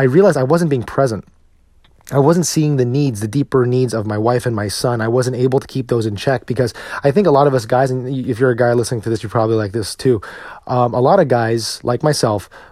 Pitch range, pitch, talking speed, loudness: 115-135 Hz, 125 Hz, 265 wpm, -16 LUFS